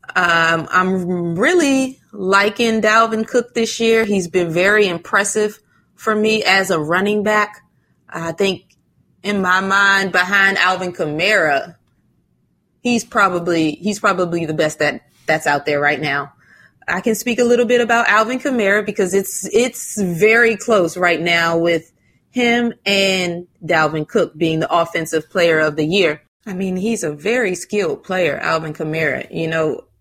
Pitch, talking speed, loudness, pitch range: 190 Hz, 155 wpm, -16 LUFS, 165-215 Hz